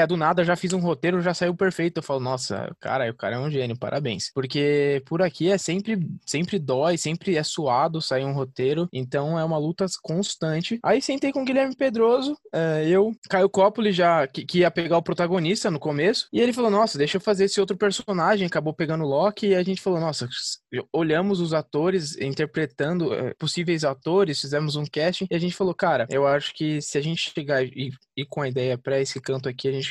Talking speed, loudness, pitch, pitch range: 210 wpm, -24 LUFS, 165 Hz, 145-190 Hz